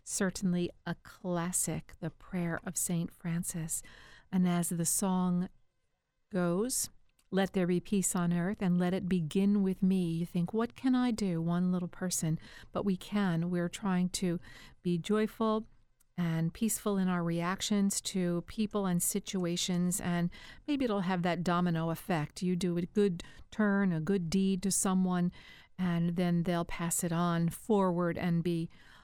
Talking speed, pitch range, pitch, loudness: 160 wpm, 175-195 Hz, 180 Hz, -32 LUFS